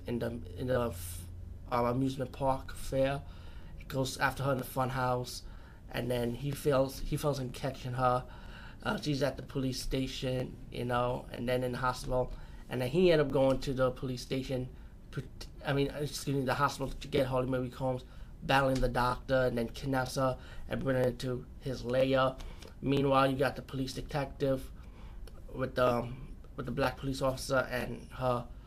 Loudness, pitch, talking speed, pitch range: -33 LUFS, 130 Hz, 180 wpm, 125-135 Hz